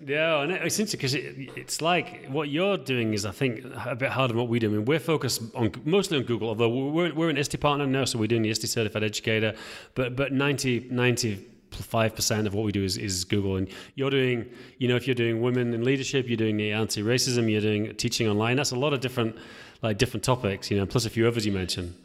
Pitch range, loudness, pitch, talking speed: 110-135 Hz, -26 LUFS, 120 Hz, 250 wpm